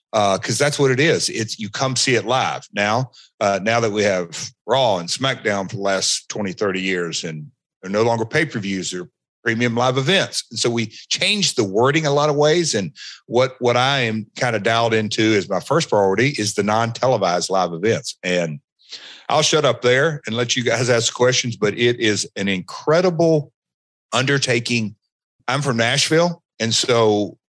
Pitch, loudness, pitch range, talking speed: 120 Hz, -19 LUFS, 105-135 Hz, 195 wpm